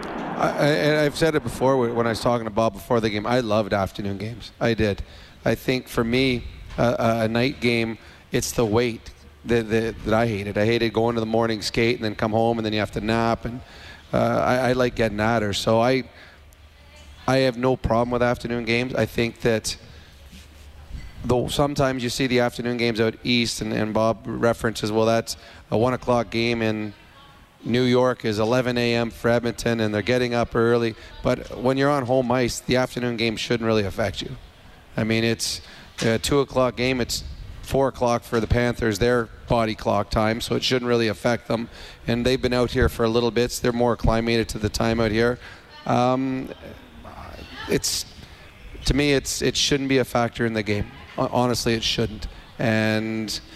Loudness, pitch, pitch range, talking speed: -23 LUFS, 115 Hz, 110-120 Hz, 200 wpm